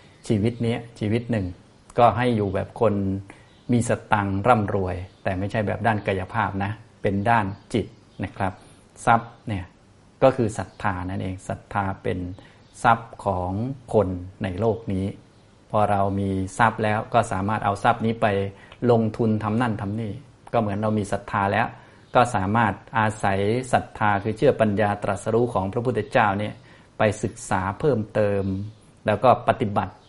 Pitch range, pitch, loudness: 100-115 Hz, 105 Hz, -24 LUFS